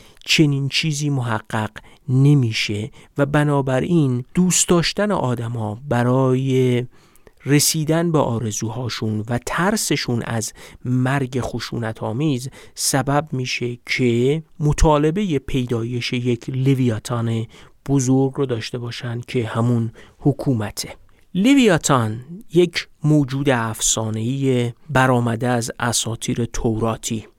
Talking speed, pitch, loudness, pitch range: 90 wpm, 130 Hz, -20 LUFS, 115-145 Hz